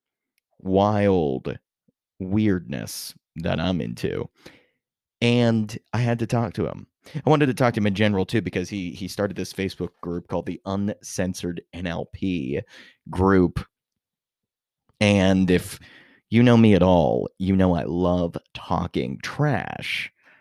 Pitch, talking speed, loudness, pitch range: 95 Hz, 135 wpm, -23 LUFS, 90-110 Hz